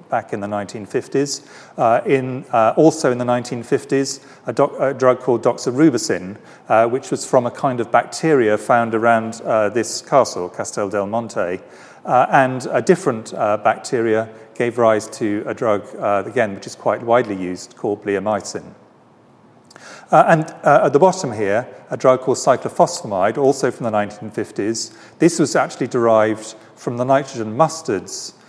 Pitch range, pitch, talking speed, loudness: 110-135 Hz, 120 Hz, 160 wpm, -18 LUFS